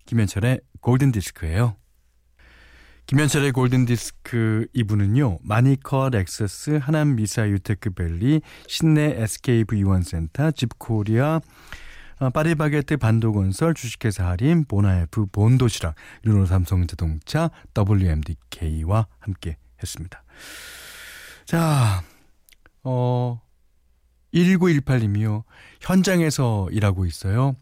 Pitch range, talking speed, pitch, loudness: 95-135 Hz, 230 characters per minute, 110 Hz, -22 LUFS